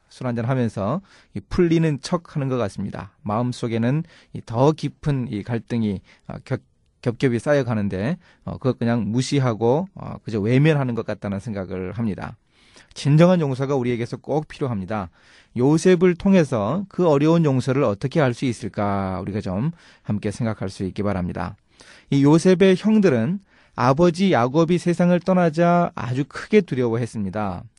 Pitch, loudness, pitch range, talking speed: 125 Hz, -21 LUFS, 105-160 Hz, 315 characters per minute